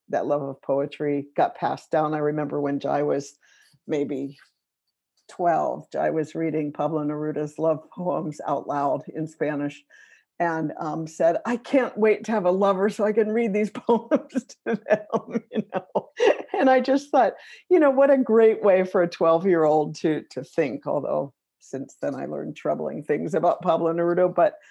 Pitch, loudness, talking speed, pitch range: 170 Hz, -24 LUFS, 175 wpm, 150-230 Hz